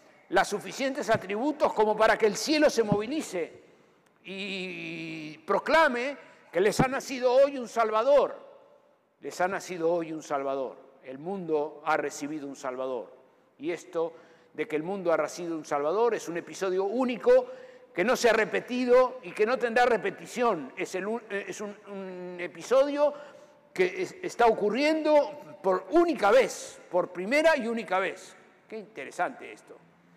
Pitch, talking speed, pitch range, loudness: 210 Hz, 150 wpm, 170-270 Hz, -27 LUFS